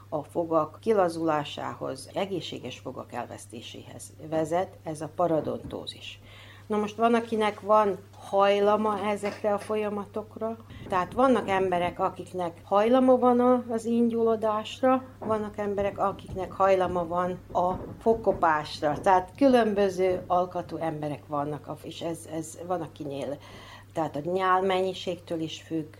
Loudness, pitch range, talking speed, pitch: -27 LUFS, 155-210 Hz, 115 wpm, 180 Hz